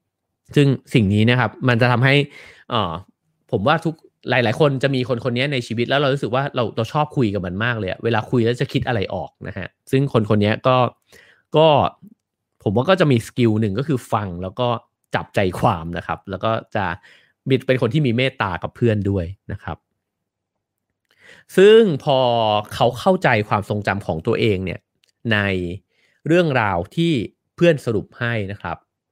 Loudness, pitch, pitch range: -19 LUFS, 120 Hz, 105-135 Hz